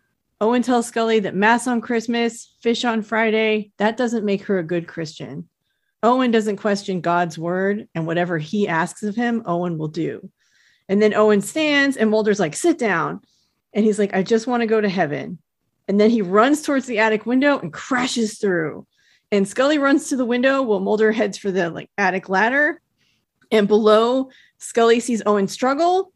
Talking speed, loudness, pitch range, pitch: 185 wpm, -19 LUFS, 190-240 Hz, 215 Hz